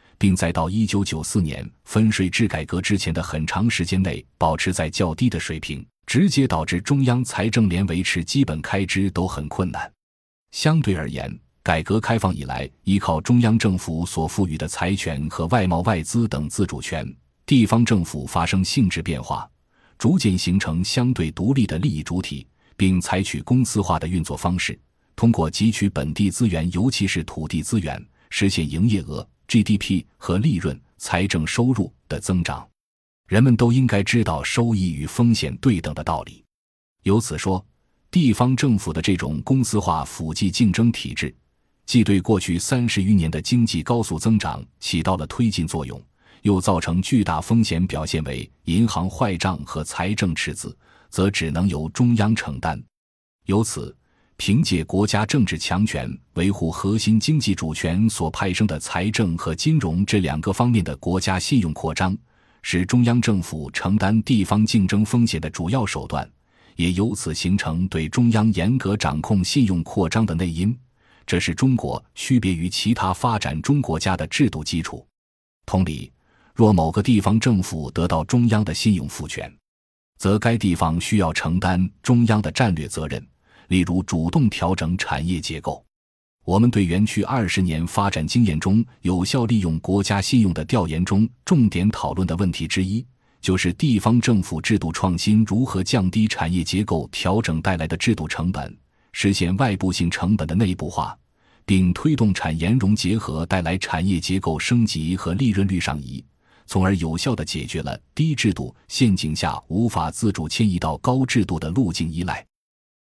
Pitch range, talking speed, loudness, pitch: 80-110 Hz, 260 characters per minute, -21 LUFS, 95 Hz